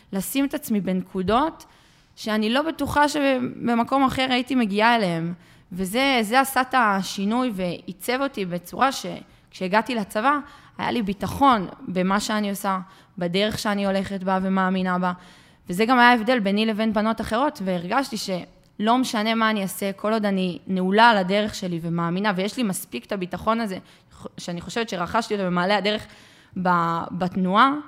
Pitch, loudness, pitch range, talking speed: 210 Hz, -23 LUFS, 185-240 Hz, 145 wpm